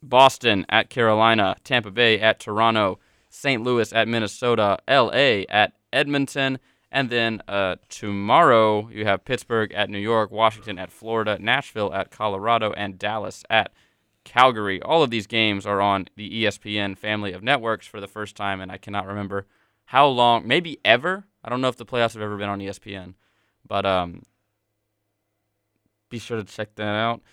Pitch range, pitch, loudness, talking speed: 100-115 Hz, 105 Hz, -21 LUFS, 165 wpm